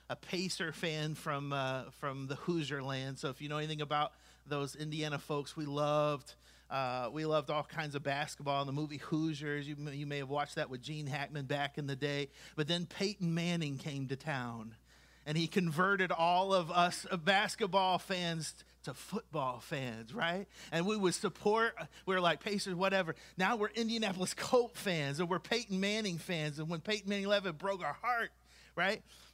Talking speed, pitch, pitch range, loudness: 190 wpm, 155 Hz, 140-185 Hz, -36 LUFS